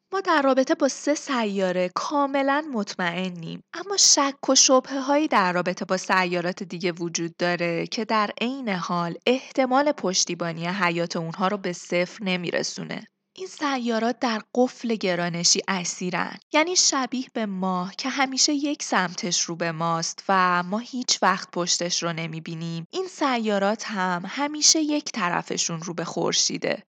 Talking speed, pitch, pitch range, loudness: 150 wpm, 200 Hz, 175-270 Hz, -23 LUFS